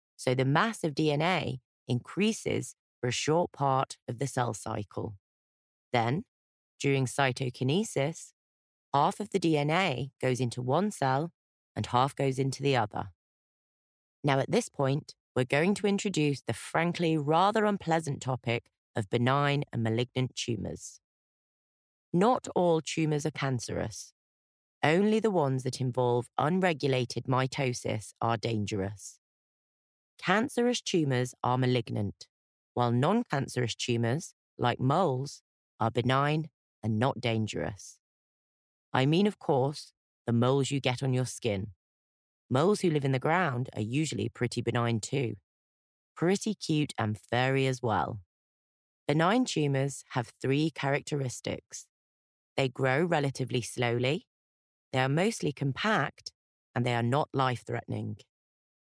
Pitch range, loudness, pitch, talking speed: 115-150 Hz, -30 LUFS, 130 Hz, 125 wpm